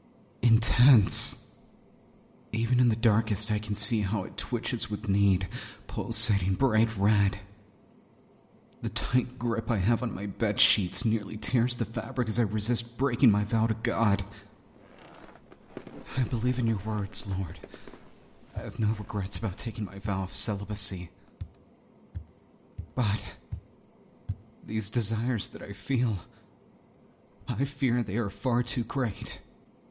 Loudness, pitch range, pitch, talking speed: -28 LUFS, 100-120 Hz, 110 Hz, 130 wpm